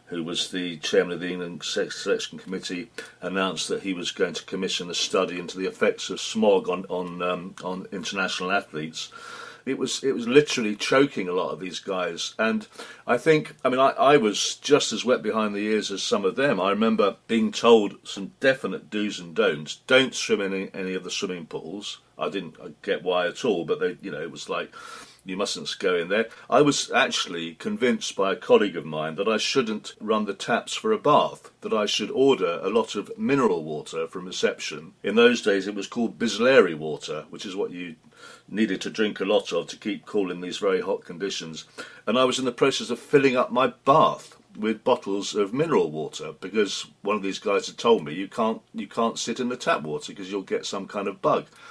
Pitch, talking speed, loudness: 120 Hz, 220 wpm, -25 LUFS